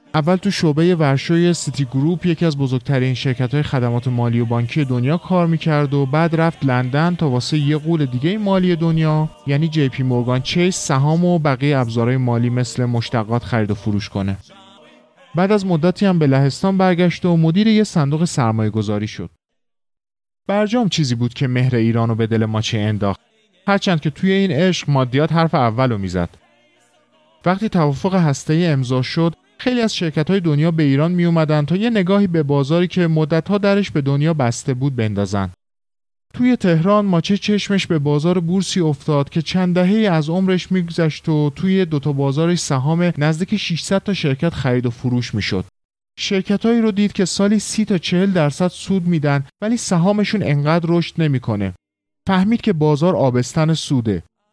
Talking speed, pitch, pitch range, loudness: 170 wpm, 155 Hz, 130-180 Hz, -17 LUFS